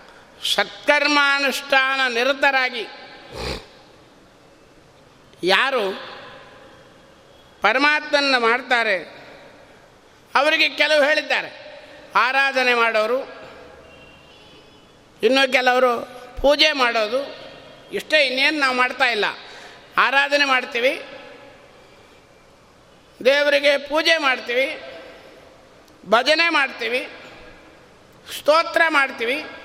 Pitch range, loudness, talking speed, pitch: 255-295 Hz, -18 LUFS, 55 wpm, 275 Hz